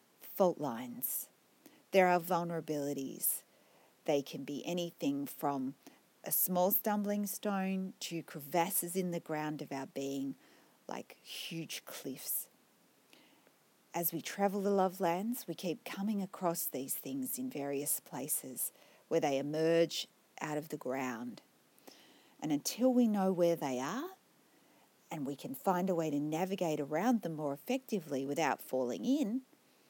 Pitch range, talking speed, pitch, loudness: 150-205 Hz, 140 wpm, 170 Hz, -36 LUFS